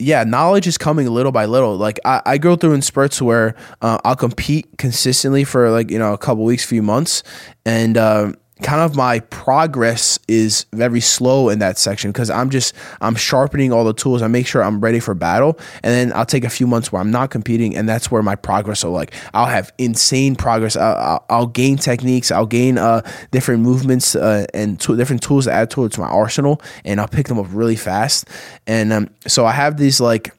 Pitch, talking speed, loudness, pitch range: 120 Hz, 225 wpm, -16 LUFS, 110-130 Hz